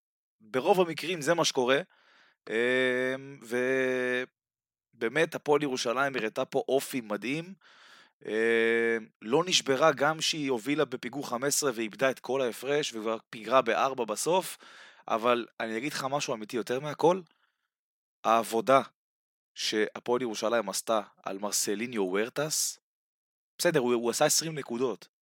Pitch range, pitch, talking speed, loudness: 115-145 Hz, 130 Hz, 115 wpm, -29 LUFS